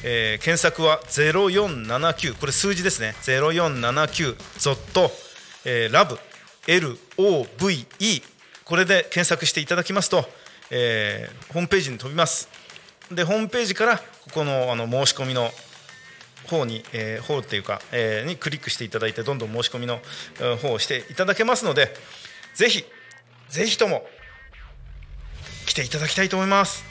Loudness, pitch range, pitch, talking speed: -22 LUFS, 120-180 Hz, 155 Hz, 295 characters per minute